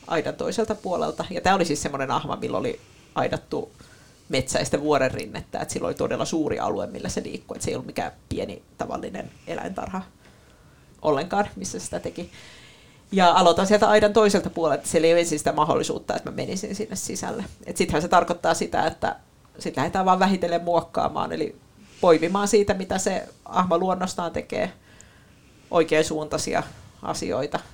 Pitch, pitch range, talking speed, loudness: 180 Hz, 165-205 Hz, 155 wpm, -24 LUFS